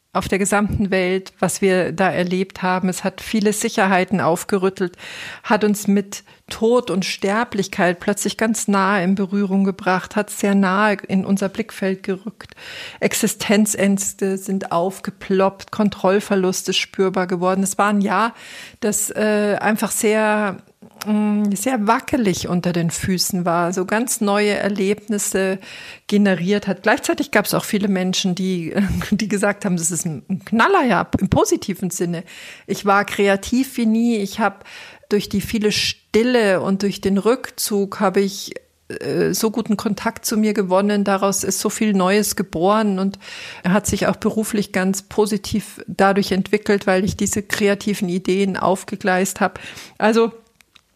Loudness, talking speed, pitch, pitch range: -19 LUFS, 150 wpm, 200 Hz, 190-210 Hz